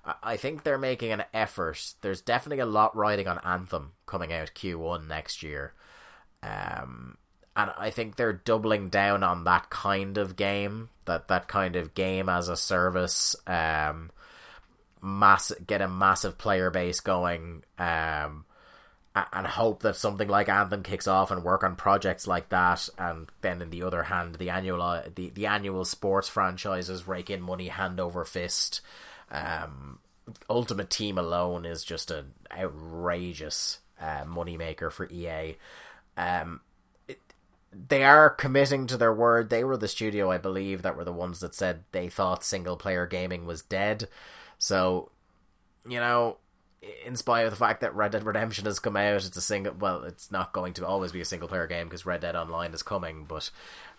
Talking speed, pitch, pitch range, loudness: 170 wpm, 95 Hz, 85-100 Hz, -28 LUFS